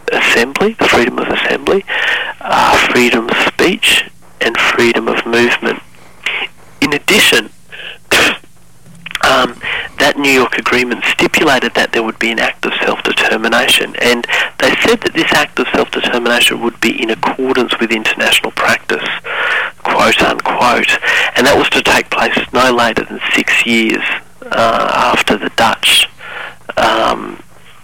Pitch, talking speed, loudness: 120 Hz, 135 wpm, -11 LUFS